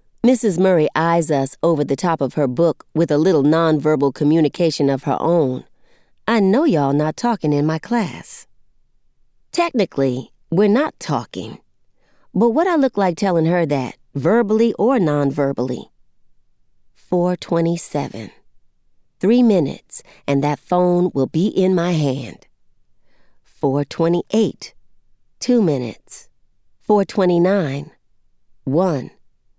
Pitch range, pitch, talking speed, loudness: 145-200 Hz, 170 Hz, 115 wpm, -18 LUFS